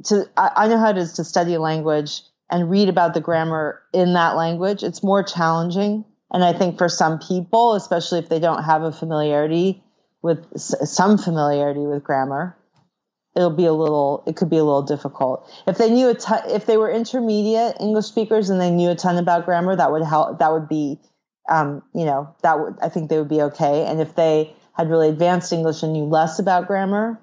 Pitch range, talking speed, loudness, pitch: 155-195 Hz, 210 wpm, -19 LUFS, 170 Hz